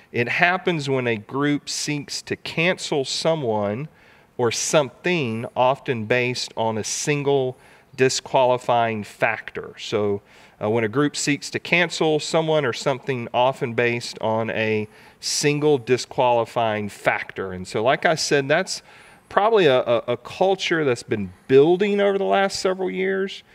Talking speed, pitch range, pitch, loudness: 140 wpm, 115-160 Hz, 135 Hz, -22 LUFS